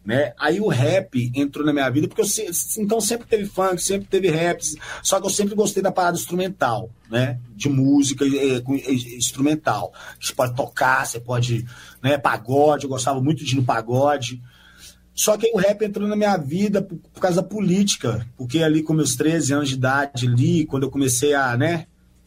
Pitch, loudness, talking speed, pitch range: 145 Hz, -21 LUFS, 200 wpm, 130-190 Hz